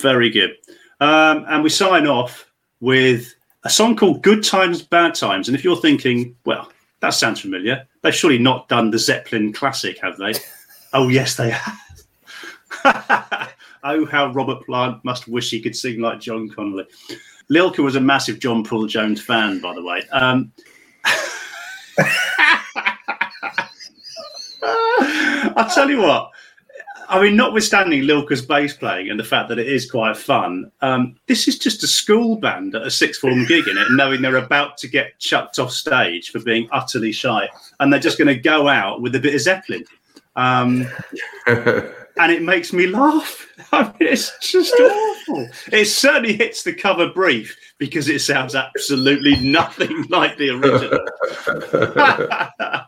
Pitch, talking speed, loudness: 145 Hz, 160 wpm, -17 LUFS